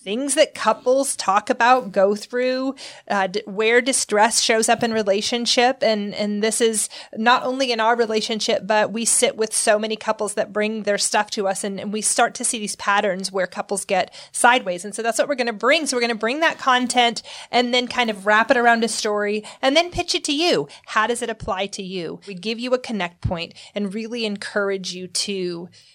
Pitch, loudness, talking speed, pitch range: 220 Hz, -20 LUFS, 220 wpm, 205-245 Hz